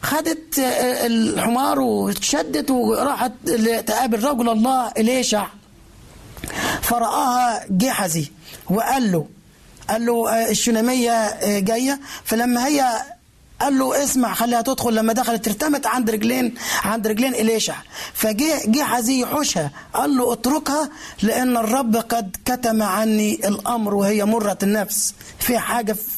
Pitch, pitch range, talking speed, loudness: 235 Hz, 220-255 Hz, 110 wpm, -20 LUFS